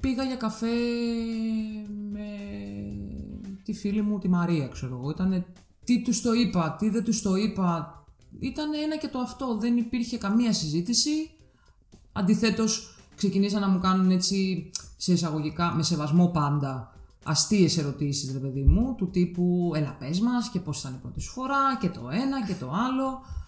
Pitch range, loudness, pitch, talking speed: 165-230 Hz, -27 LUFS, 195 Hz, 160 wpm